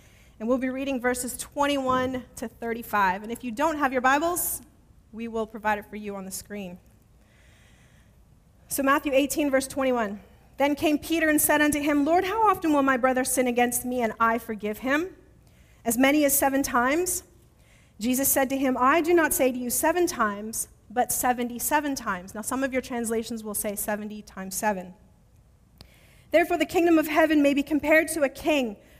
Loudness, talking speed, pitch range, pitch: -25 LUFS, 190 wpm, 230-295 Hz, 260 Hz